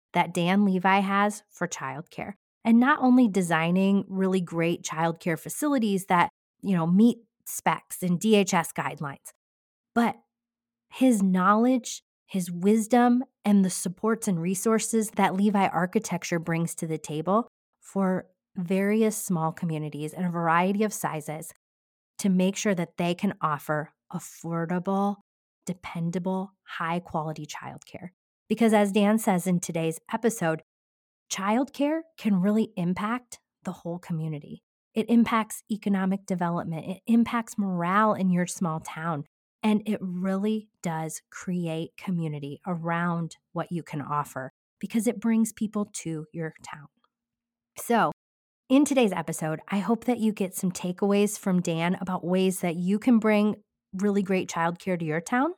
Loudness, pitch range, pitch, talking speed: -26 LUFS, 165-210 Hz, 185 Hz, 135 wpm